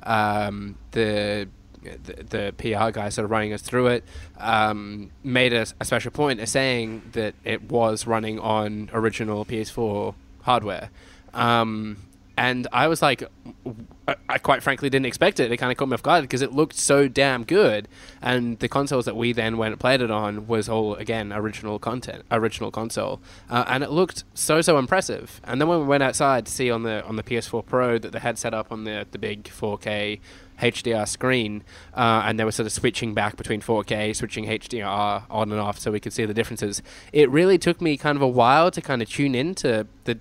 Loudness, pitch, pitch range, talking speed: -23 LUFS, 115 Hz, 105-125 Hz, 210 wpm